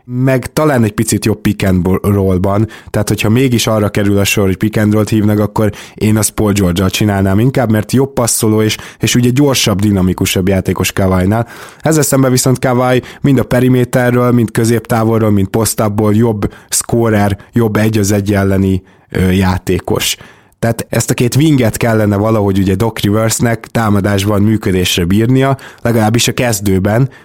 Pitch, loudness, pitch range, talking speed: 110 Hz, -12 LUFS, 100-120 Hz, 165 wpm